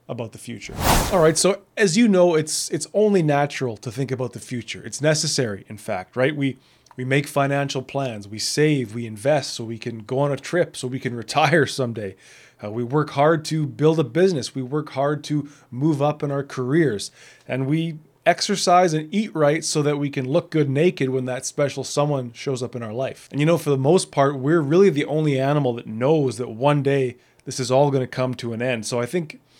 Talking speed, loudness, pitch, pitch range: 225 wpm, -21 LUFS, 140 Hz, 125-155 Hz